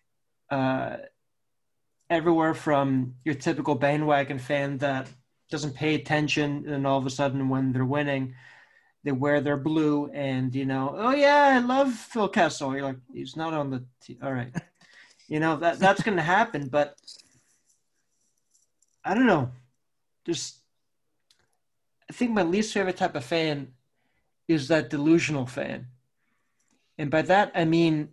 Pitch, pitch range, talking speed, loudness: 145 Hz, 135-165 Hz, 150 wpm, -25 LUFS